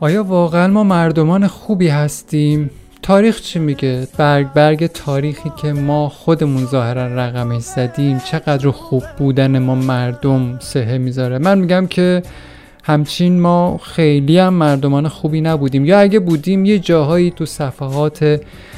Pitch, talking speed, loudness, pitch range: 150 Hz, 135 wpm, -14 LUFS, 135-175 Hz